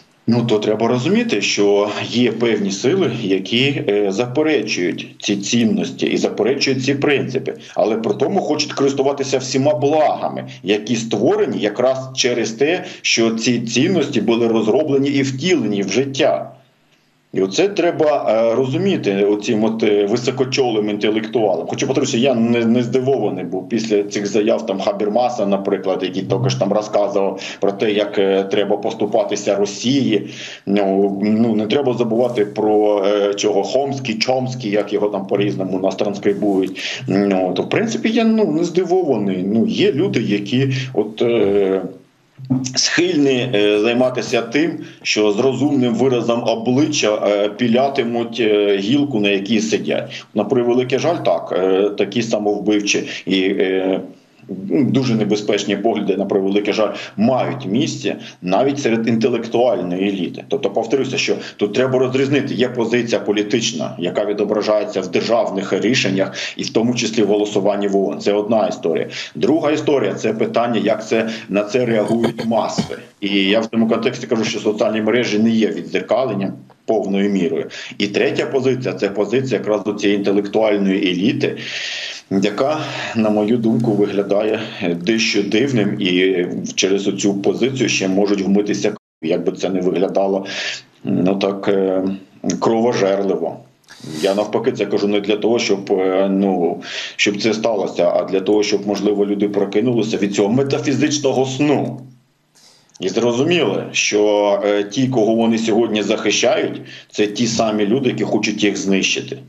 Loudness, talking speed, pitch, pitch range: -17 LUFS, 140 wpm, 105 Hz, 100-125 Hz